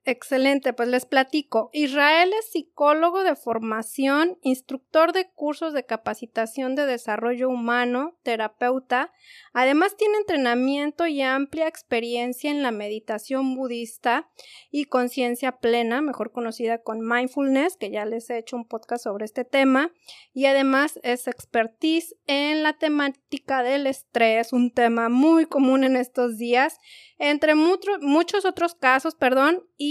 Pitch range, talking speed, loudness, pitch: 240-300 Hz, 135 wpm, -23 LUFS, 265 Hz